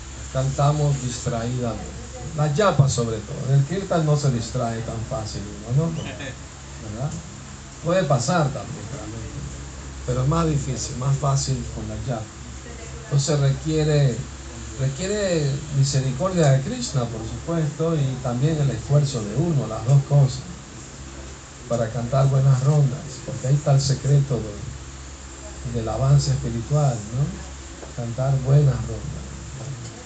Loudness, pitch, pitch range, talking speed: -23 LUFS, 130 Hz, 110-145 Hz, 125 wpm